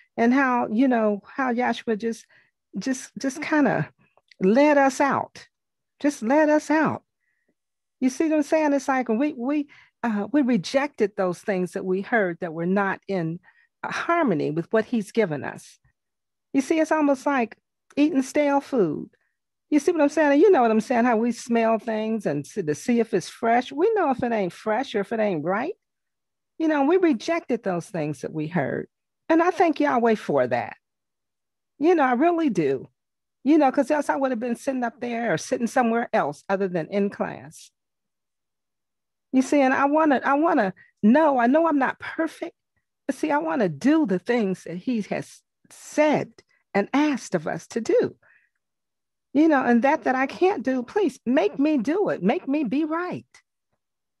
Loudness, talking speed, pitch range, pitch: -23 LUFS, 190 wpm, 220-300 Hz, 260 Hz